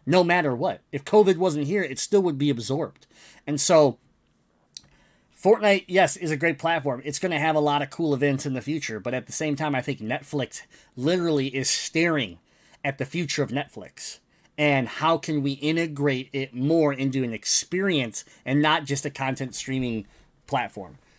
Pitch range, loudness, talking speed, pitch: 135-165 Hz, -24 LUFS, 185 wpm, 145 Hz